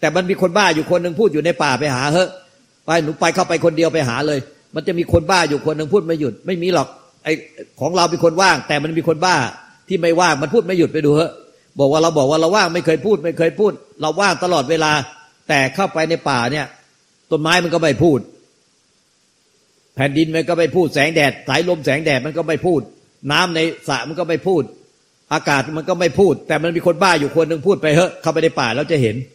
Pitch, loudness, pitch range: 160 Hz, -17 LUFS, 150-175 Hz